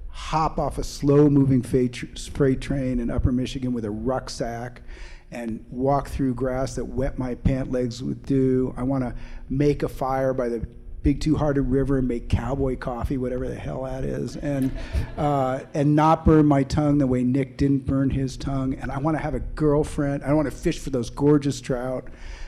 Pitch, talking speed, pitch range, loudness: 135 Hz, 195 wpm, 125-145 Hz, -24 LUFS